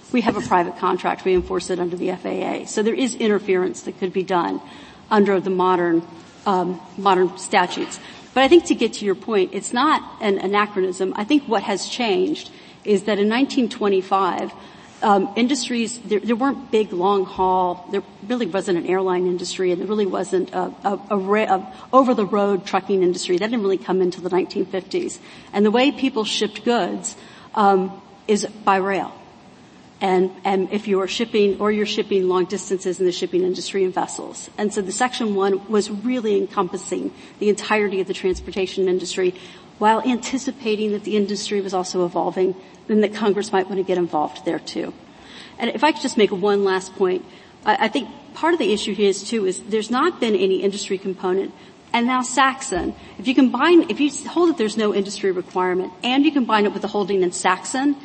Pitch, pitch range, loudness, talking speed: 200 Hz, 185-225 Hz, -21 LUFS, 195 wpm